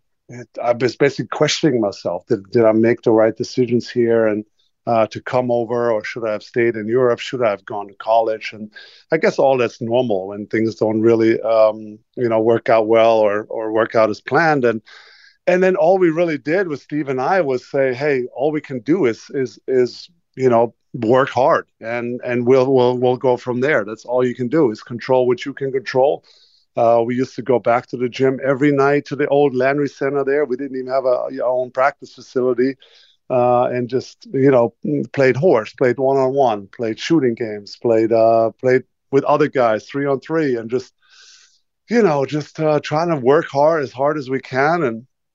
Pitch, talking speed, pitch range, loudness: 125 Hz, 215 wpm, 115-140 Hz, -18 LUFS